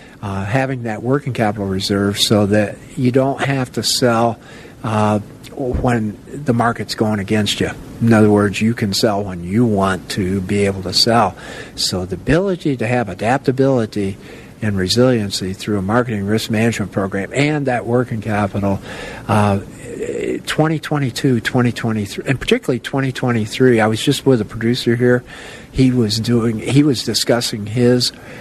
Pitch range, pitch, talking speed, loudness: 105-125 Hz, 115 Hz, 150 wpm, -17 LUFS